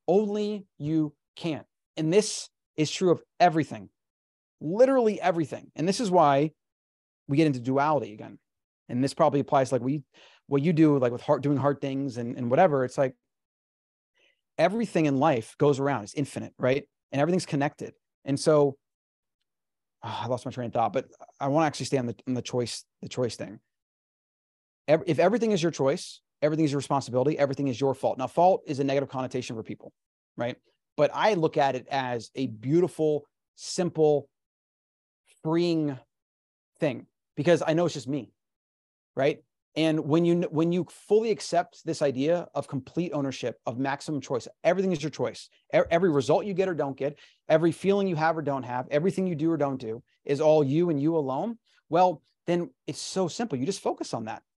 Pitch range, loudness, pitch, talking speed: 130-170 Hz, -27 LUFS, 145 Hz, 185 wpm